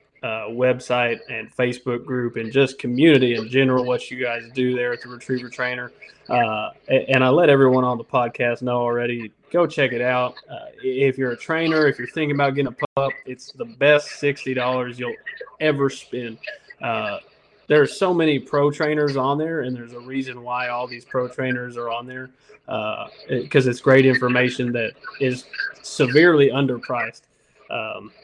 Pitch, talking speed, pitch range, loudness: 125 Hz, 180 wpm, 125-140 Hz, -21 LUFS